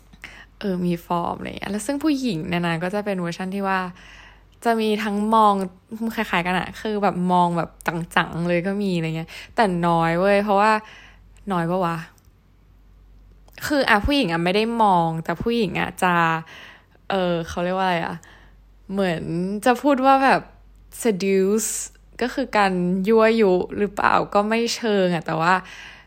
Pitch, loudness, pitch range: 185 Hz, -21 LUFS, 170-215 Hz